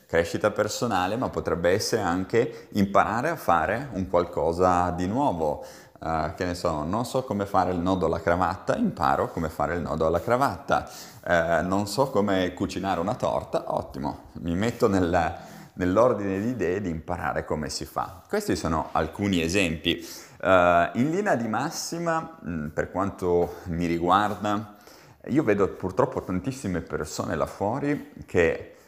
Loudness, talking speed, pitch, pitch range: -26 LUFS, 150 wpm, 95 Hz, 85-110 Hz